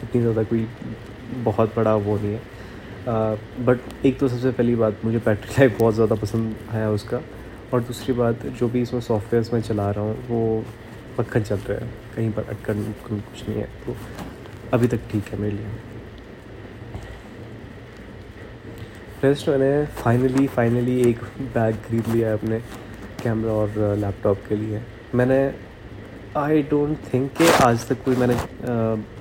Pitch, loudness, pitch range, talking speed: 115 Hz, -22 LUFS, 105-120 Hz, 160 wpm